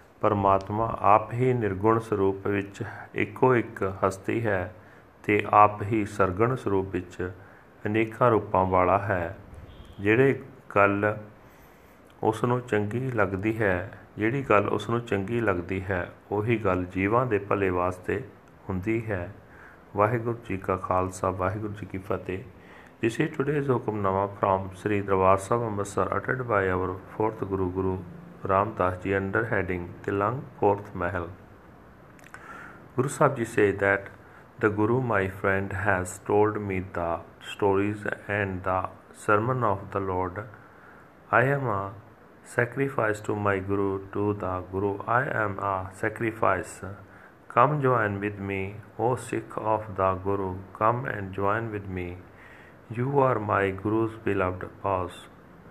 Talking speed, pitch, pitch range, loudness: 135 wpm, 100 Hz, 95-110 Hz, -27 LUFS